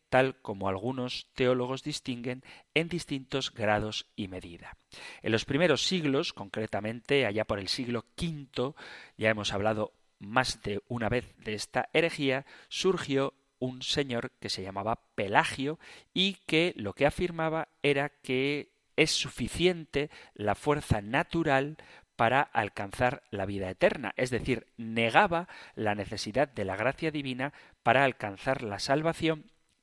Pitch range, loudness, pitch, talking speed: 110-145 Hz, -30 LUFS, 130 Hz, 135 wpm